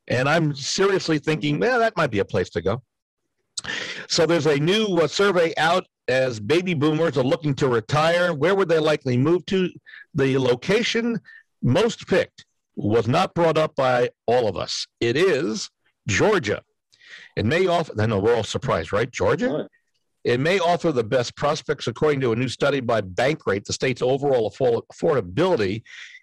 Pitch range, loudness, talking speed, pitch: 130-175 Hz, -22 LUFS, 170 wpm, 155 Hz